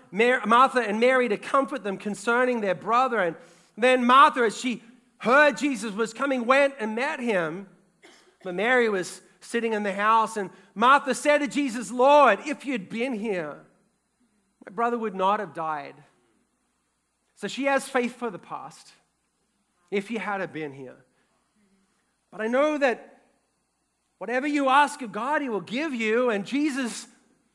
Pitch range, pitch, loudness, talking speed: 205-260 Hz, 235 Hz, -24 LUFS, 160 wpm